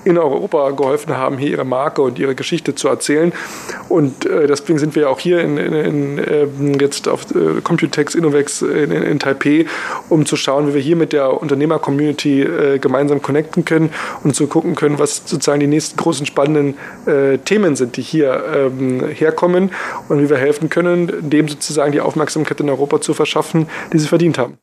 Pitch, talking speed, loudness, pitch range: 150 Hz, 195 wpm, -15 LUFS, 145-160 Hz